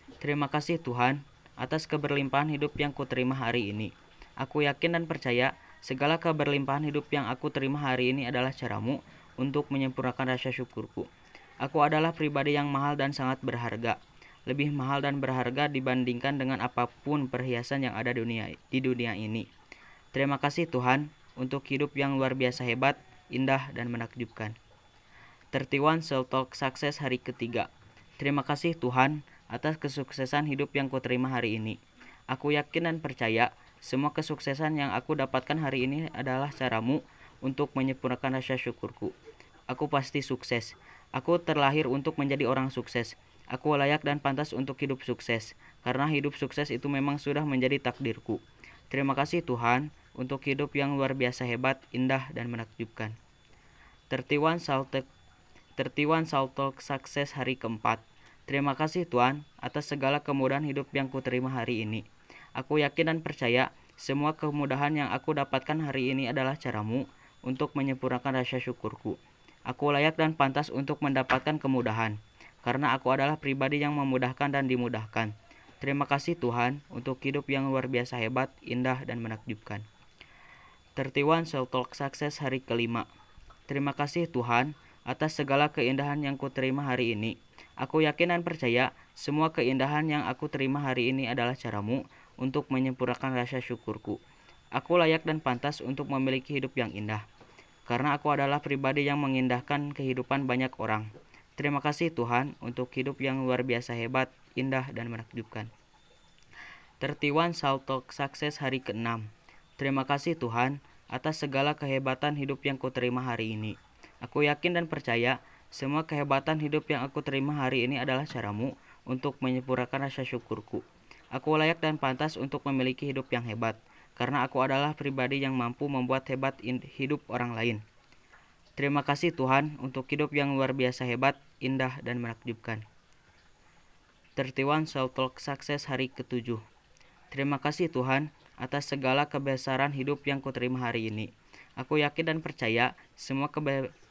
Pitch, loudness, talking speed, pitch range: 135 Hz, -30 LUFS, 145 wpm, 125-145 Hz